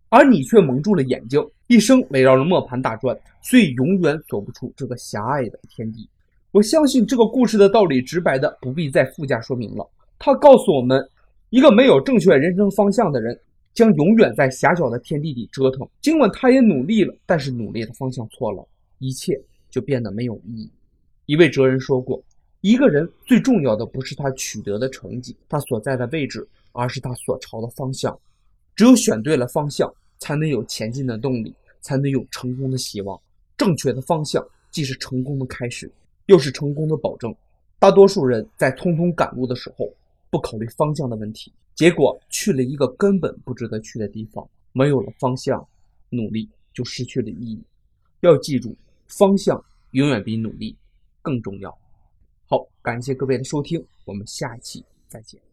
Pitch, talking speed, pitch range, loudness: 130 Hz, 280 characters per minute, 120-175 Hz, -19 LUFS